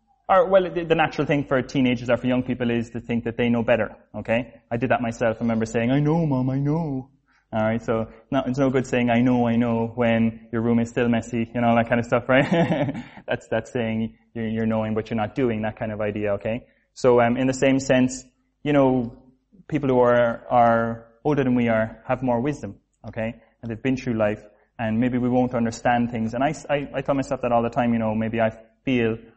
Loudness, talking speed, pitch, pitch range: -23 LUFS, 235 wpm, 120 Hz, 115-130 Hz